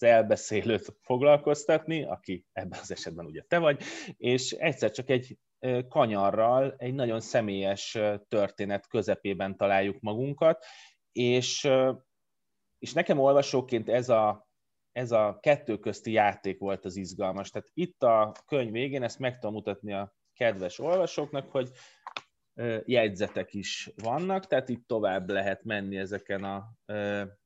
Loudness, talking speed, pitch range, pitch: -29 LUFS, 125 wpm, 100-130 Hz, 115 Hz